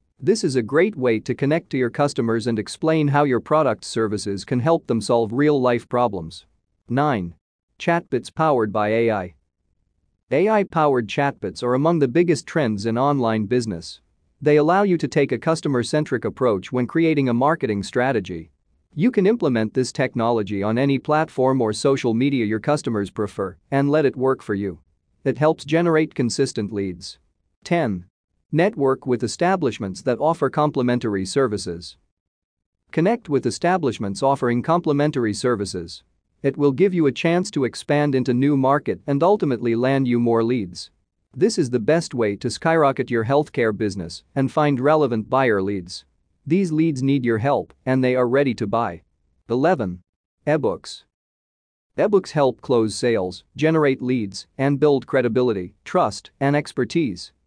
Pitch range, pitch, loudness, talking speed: 105-145 Hz, 125 Hz, -21 LUFS, 155 wpm